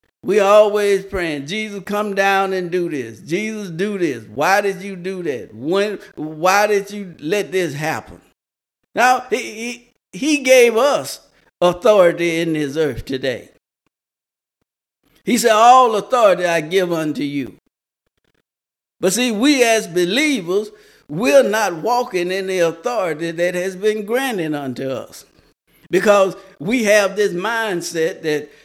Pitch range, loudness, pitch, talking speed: 170-225 Hz, -17 LUFS, 195 Hz, 140 wpm